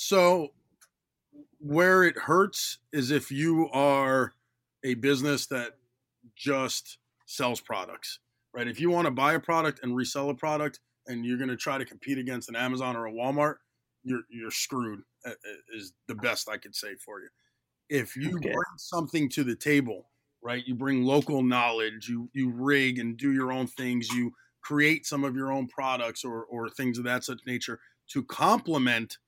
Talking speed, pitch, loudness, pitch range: 175 wpm, 130 Hz, -28 LUFS, 120-145 Hz